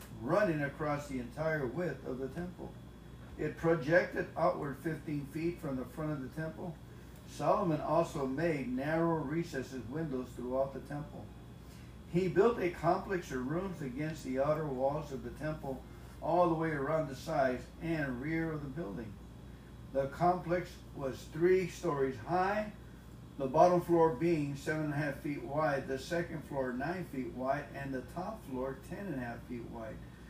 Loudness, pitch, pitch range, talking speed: -35 LUFS, 145 Hz, 130-165 Hz, 165 wpm